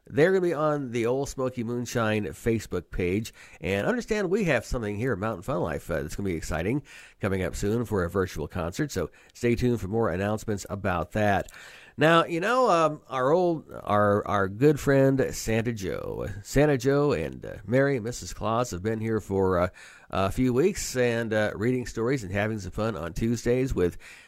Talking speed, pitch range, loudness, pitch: 200 wpm, 100-130 Hz, -27 LUFS, 110 Hz